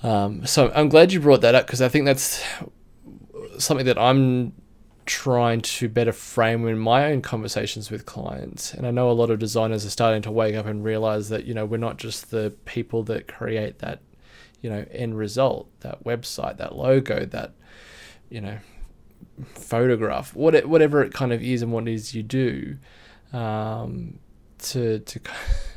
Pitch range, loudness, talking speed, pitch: 110-125 Hz, -22 LUFS, 175 wpm, 115 Hz